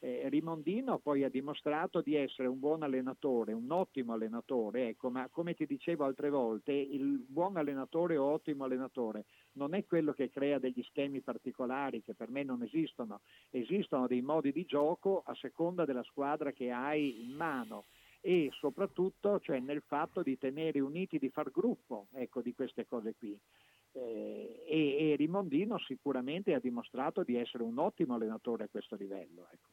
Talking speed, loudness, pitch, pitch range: 170 wpm, -37 LUFS, 140 Hz, 125-160 Hz